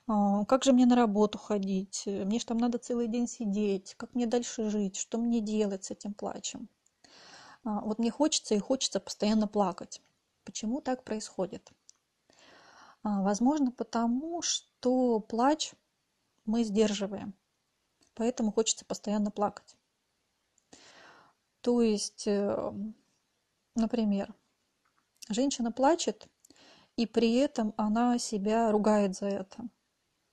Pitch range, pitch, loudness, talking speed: 210-240 Hz, 225 Hz, -30 LUFS, 110 wpm